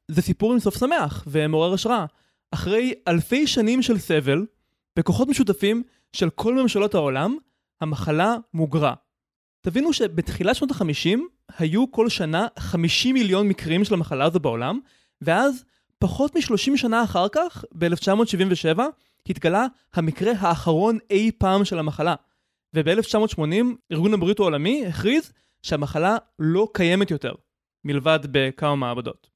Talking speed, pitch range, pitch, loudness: 125 wpm, 160-235 Hz, 195 Hz, -22 LUFS